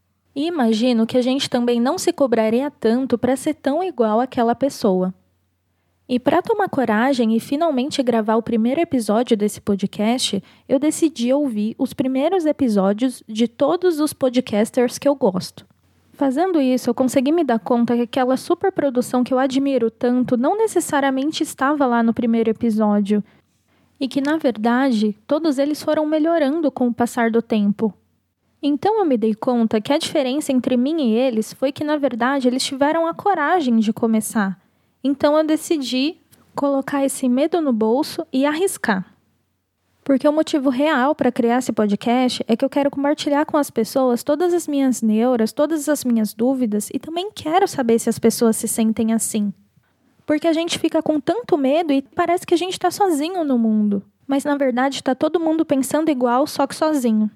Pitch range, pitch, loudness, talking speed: 230-300 Hz, 265 Hz, -19 LUFS, 175 wpm